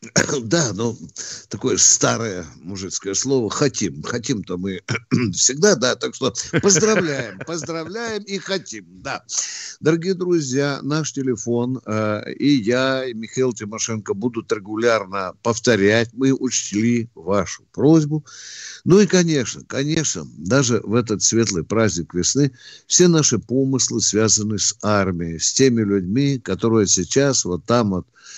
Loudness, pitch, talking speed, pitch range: -19 LUFS, 120 Hz, 125 wpm, 105-140 Hz